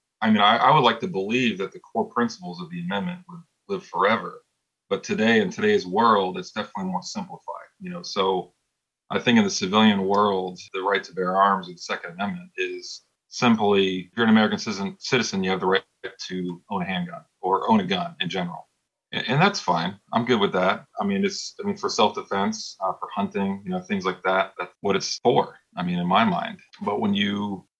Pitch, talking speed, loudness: 180 Hz, 220 wpm, -23 LUFS